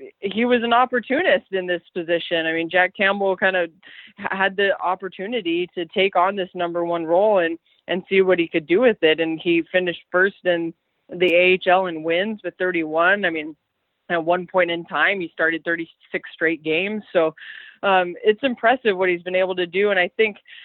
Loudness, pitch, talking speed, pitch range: -20 LUFS, 180 Hz, 200 wpm, 170-195 Hz